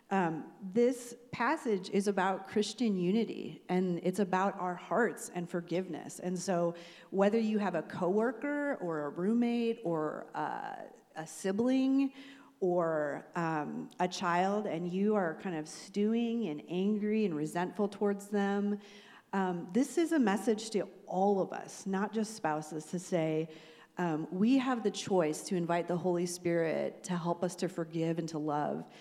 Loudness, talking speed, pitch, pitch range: -33 LUFS, 155 wpm, 190 Hz, 170-215 Hz